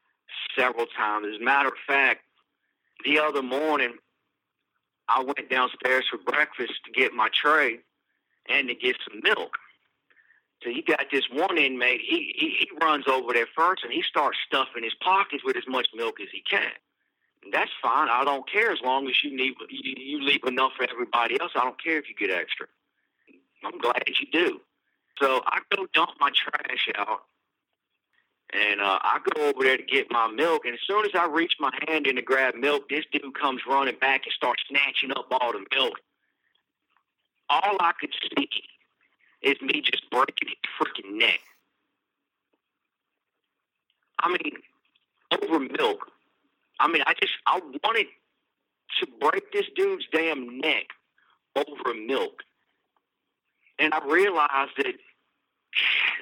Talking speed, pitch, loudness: 165 wpm, 150 Hz, -25 LUFS